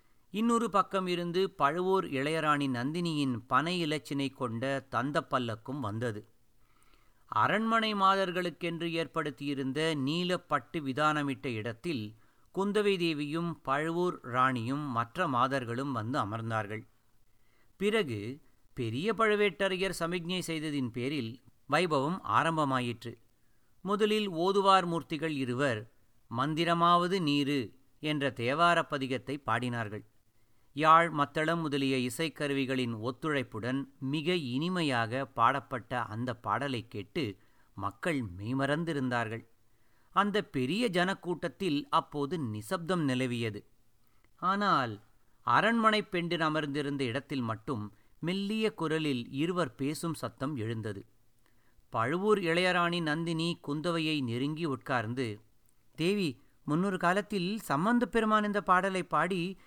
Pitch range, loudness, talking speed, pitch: 120-175 Hz, -31 LUFS, 90 wpm, 145 Hz